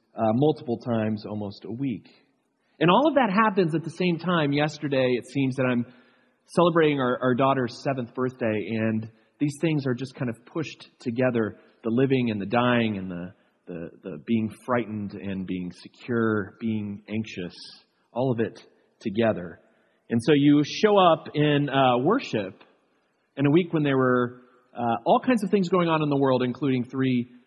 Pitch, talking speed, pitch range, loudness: 125 Hz, 180 wpm, 110-145 Hz, -25 LUFS